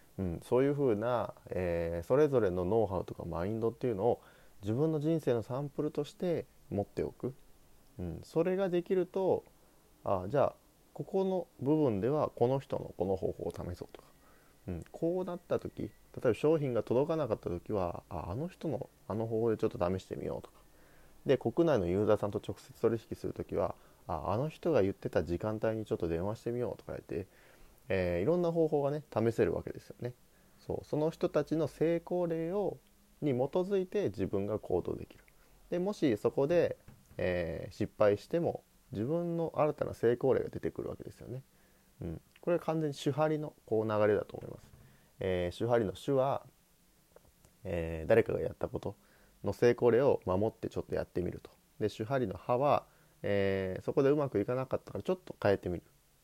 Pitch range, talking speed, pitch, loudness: 100-155 Hz, 360 characters per minute, 120 Hz, -34 LUFS